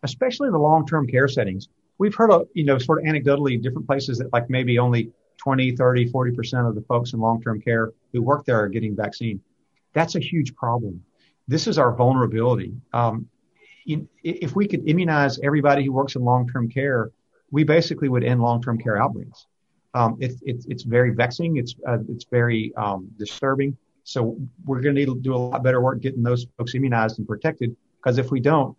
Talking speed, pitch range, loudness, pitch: 200 wpm, 120-140 Hz, -22 LUFS, 125 Hz